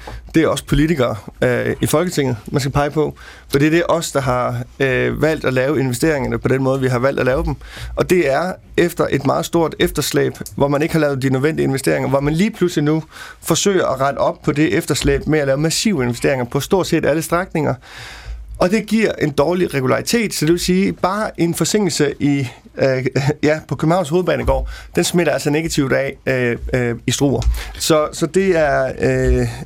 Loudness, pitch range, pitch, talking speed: -17 LUFS, 135-165 Hz, 150 Hz, 210 wpm